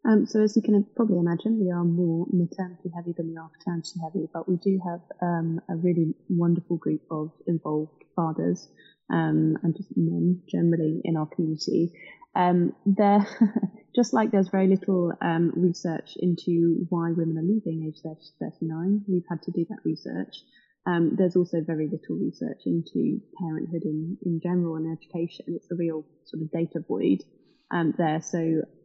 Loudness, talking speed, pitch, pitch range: -26 LUFS, 175 wpm, 170 Hz, 165-185 Hz